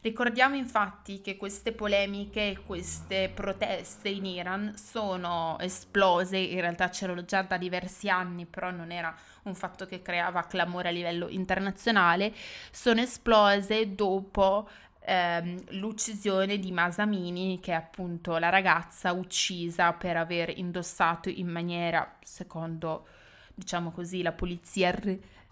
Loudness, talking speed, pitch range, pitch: -29 LUFS, 130 wpm, 175-200 Hz, 185 Hz